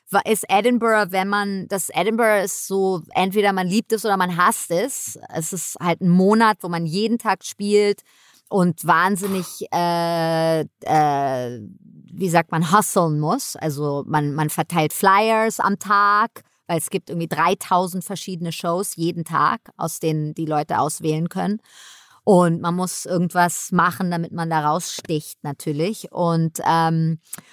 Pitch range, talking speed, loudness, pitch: 160-195 Hz, 150 wpm, -20 LUFS, 180 Hz